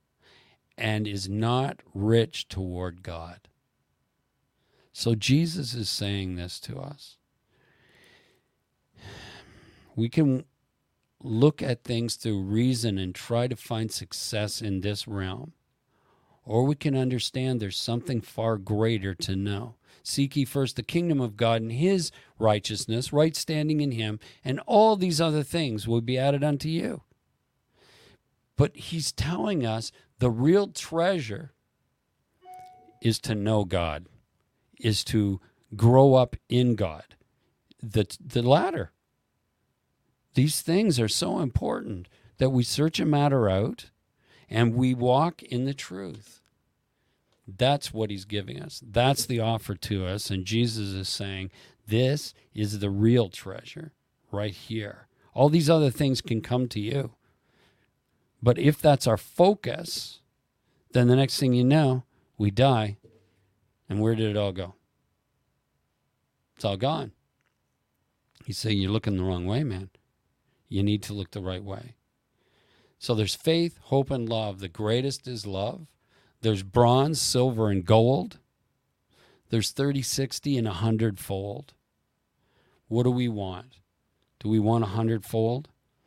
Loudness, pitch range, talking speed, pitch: -26 LUFS, 105-135 Hz, 135 wpm, 115 Hz